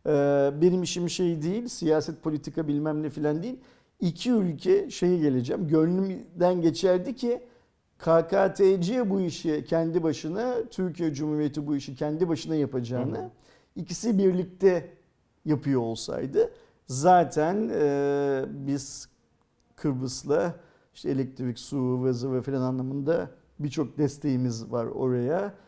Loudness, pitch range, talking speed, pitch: -27 LUFS, 140-185 Hz, 110 wpm, 160 Hz